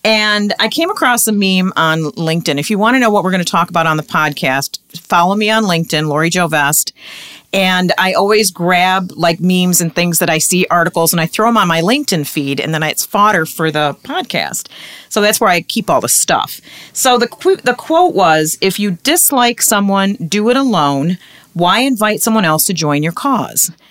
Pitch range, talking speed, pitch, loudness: 160-220 Hz, 215 wpm, 185 Hz, -12 LUFS